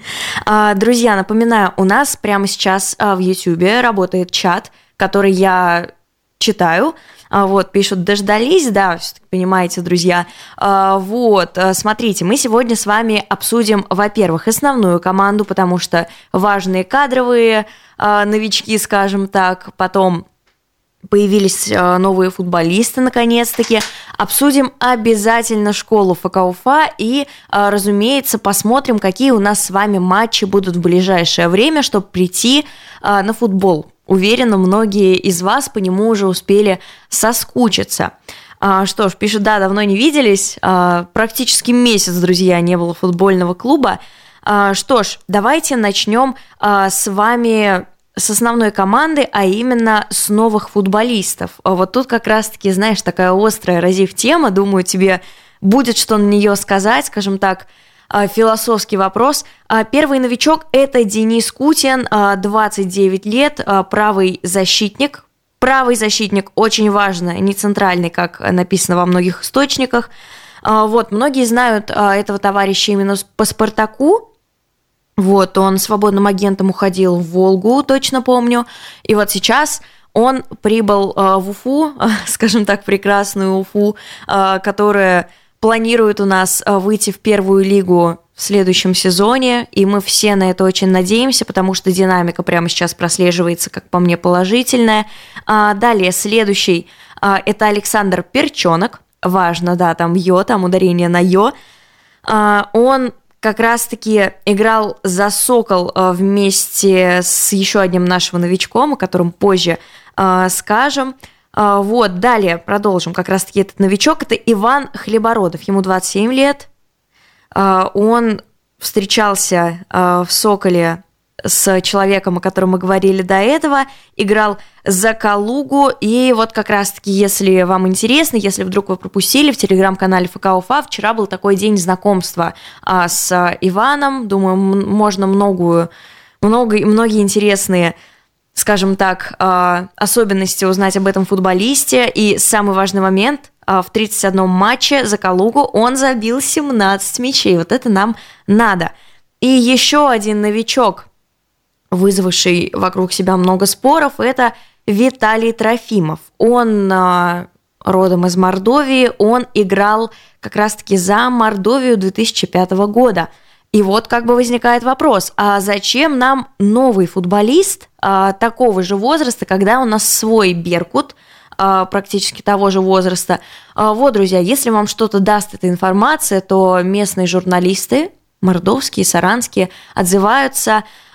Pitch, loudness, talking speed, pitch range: 205 Hz, -13 LUFS, 130 wpm, 190-230 Hz